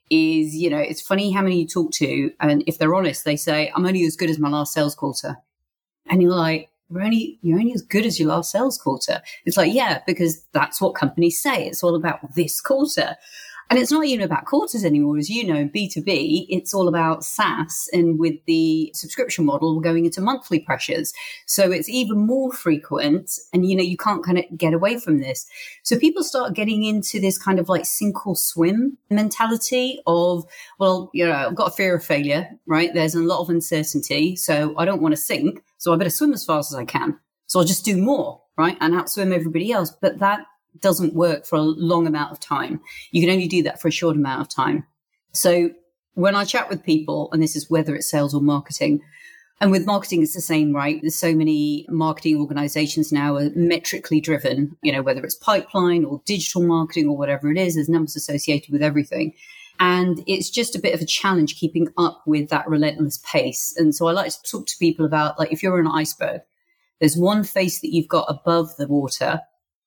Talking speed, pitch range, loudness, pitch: 215 wpm, 155-190 Hz, -20 LUFS, 170 Hz